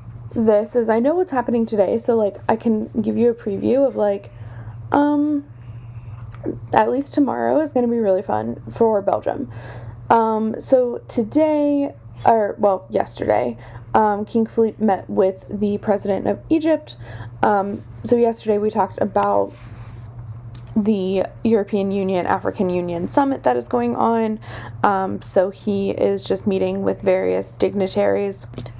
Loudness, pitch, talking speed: -20 LUFS, 200 Hz, 145 wpm